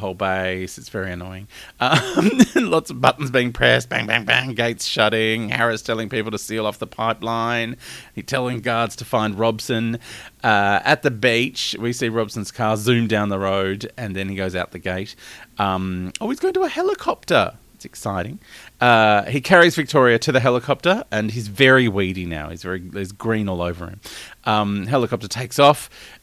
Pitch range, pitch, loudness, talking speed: 100-125 Hz, 115 Hz, -19 LUFS, 185 wpm